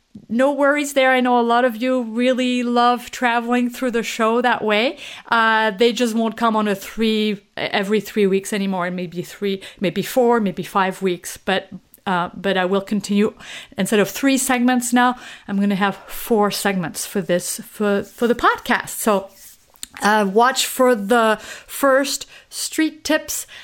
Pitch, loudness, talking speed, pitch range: 225 Hz, -19 LUFS, 170 wpm, 200-250 Hz